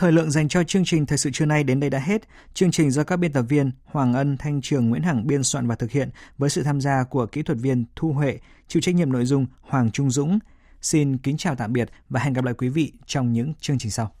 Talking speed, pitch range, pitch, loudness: 280 wpm, 130-155 Hz, 140 Hz, -23 LUFS